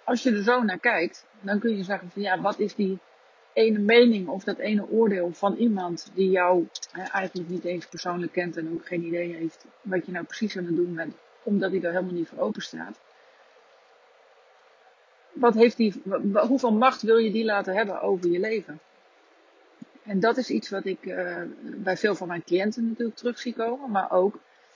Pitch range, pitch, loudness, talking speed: 180-230 Hz, 200 Hz, -25 LUFS, 195 wpm